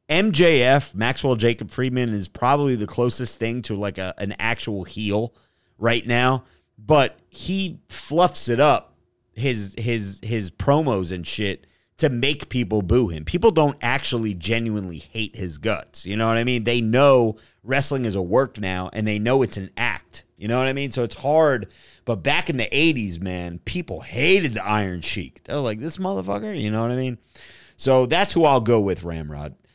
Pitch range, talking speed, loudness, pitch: 100-135 Hz, 190 wpm, -22 LUFS, 115 Hz